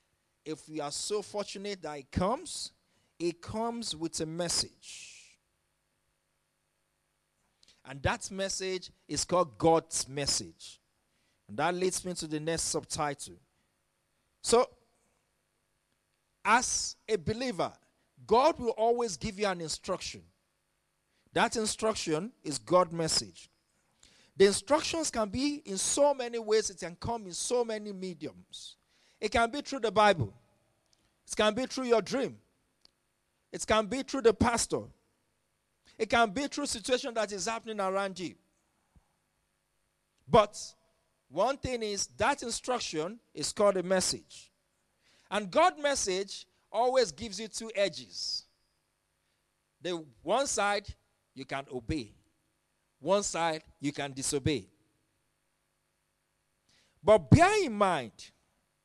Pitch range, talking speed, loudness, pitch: 155-230 Hz, 120 wpm, -31 LUFS, 195 Hz